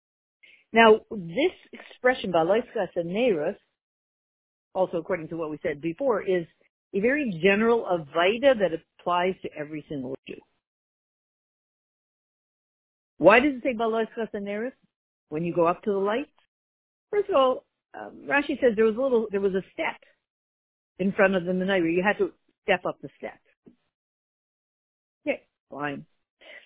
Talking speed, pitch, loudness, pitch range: 145 wpm, 195 Hz, -25 LUFS, 175-235 Hz